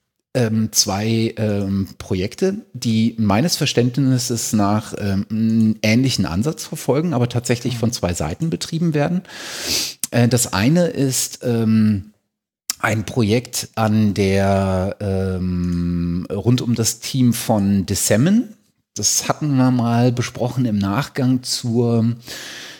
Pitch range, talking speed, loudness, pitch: 100-125 Hz, 115 wpm, -19 LUFS, 115 Hz